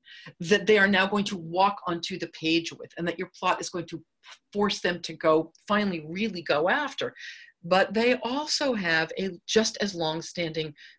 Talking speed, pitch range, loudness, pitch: 190 wpm, 165-210 Hz, -26 LUFS, 180 Hz